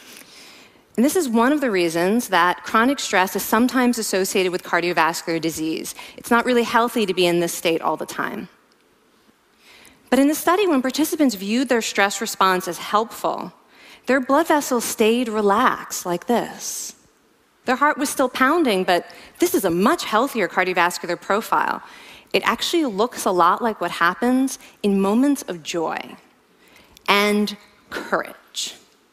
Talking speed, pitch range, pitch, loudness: 150 wpm, 185-255 Hz, 220 Hz, -20 LUFS